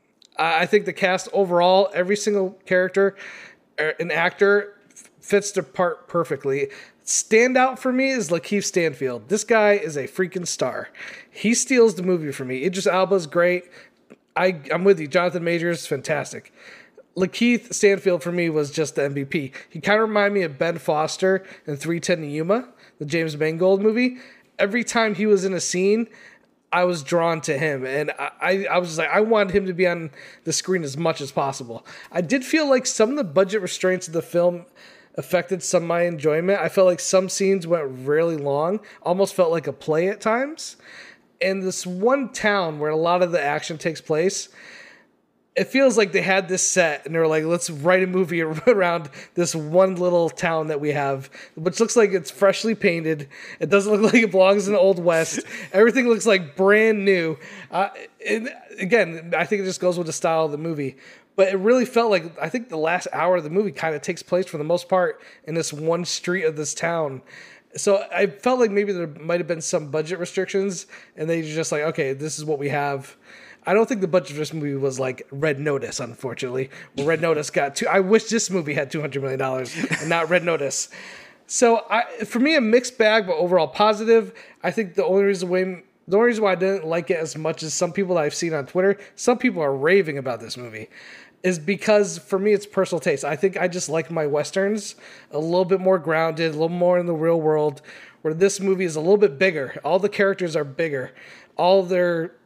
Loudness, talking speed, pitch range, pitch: -21 LUFS, 210 wpm, 160-200 Hz, 180 Hz